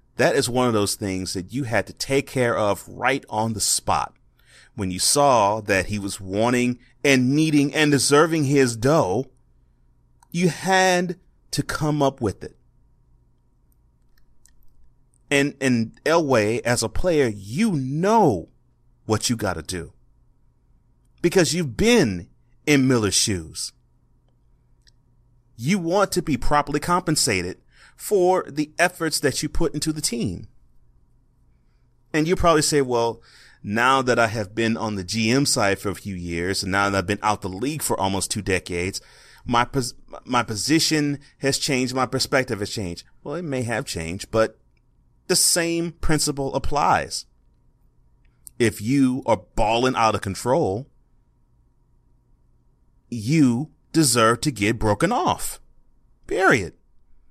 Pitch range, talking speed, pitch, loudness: 105-145 Hz, 140 wpm, 120 Hz, -21 LUFS